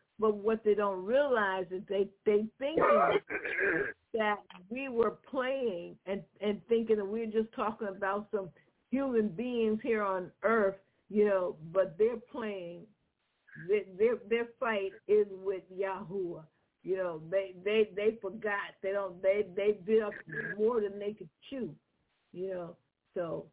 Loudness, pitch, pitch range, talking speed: -33 LUFS, 205 Hz, 190-225 Hz, 155 wpm